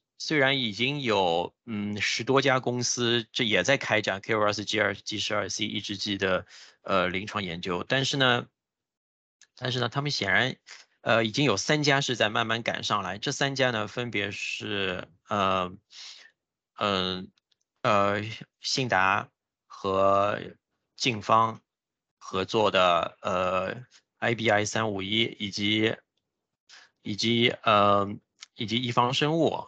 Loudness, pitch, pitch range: -26 LUFS, 110 Hz, 100-125 Hz